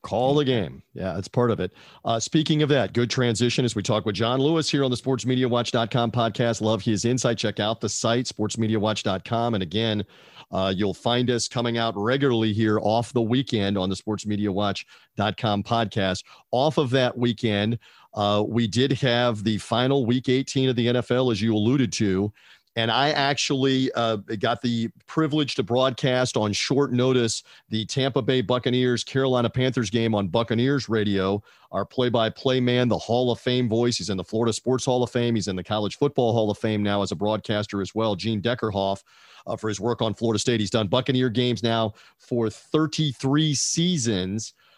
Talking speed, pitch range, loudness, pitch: 190 wpm, 105-130 Hz, -24 LUFS, 115 Hz